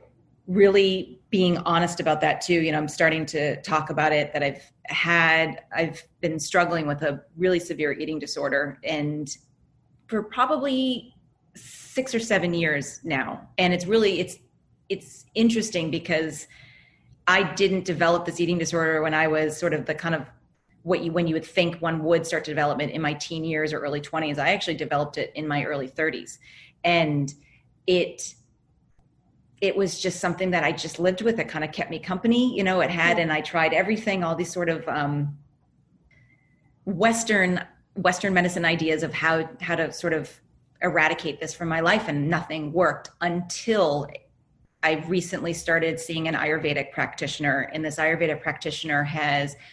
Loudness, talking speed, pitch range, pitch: -24 LUFS, 170 wpm, 150-180 Hz, 165 Hz